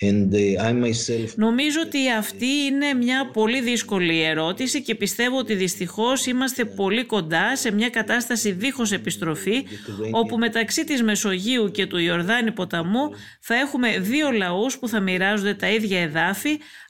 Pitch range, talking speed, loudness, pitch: 185-250 Hz, 135 wpm, -22 LUFS, 220 Hz